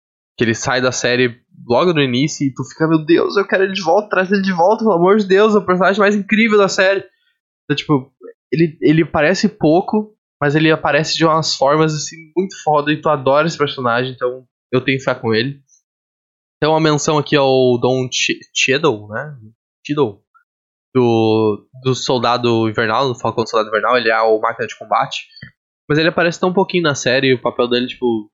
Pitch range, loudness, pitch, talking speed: 125-180 Hz, -15 LUFS, 150 Hz, 205 wpm